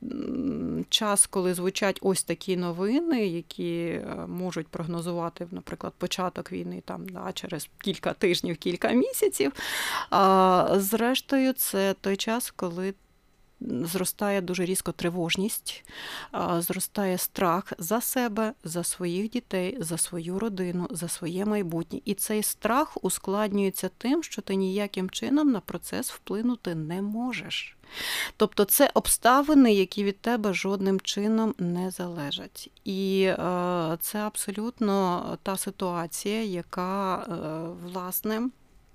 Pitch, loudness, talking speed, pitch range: 195 Hz, -27 LUFS, 110 wpm, 175-215 Hz